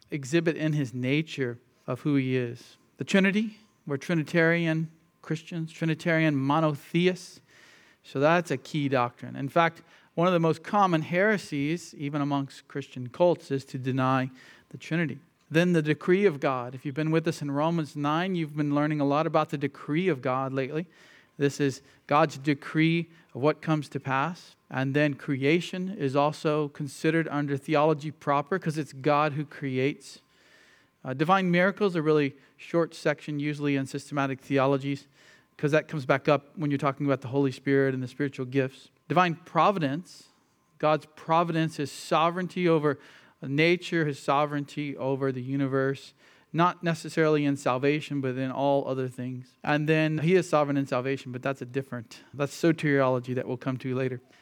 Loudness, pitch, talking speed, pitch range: -27 LUFS, 150 Hz, 165 wpm, 135-160 Hz